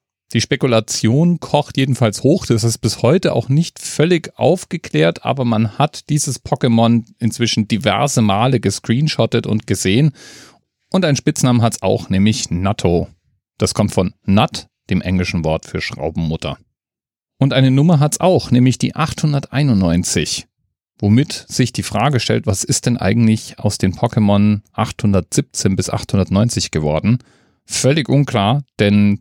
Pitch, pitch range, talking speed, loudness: 115 Hz, 100-140 Hz, 140 wpm, -16 LUFS